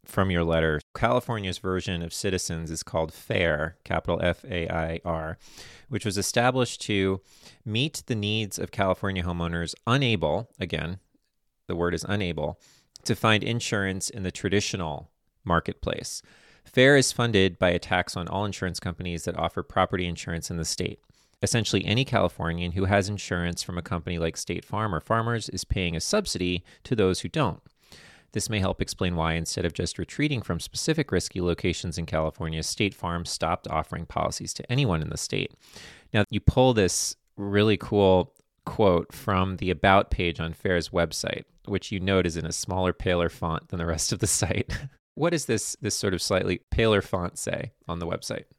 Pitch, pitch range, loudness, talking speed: 95 Hz, 85-105 Hz, -27 LUFS, 180 wpm